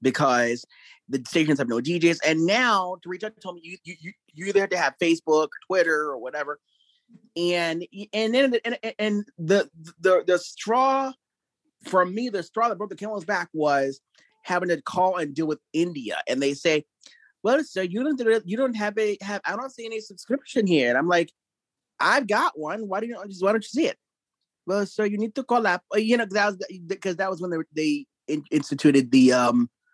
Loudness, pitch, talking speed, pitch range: -24 LUFS, 190 Hz, 205 wpm, 160-220 Hz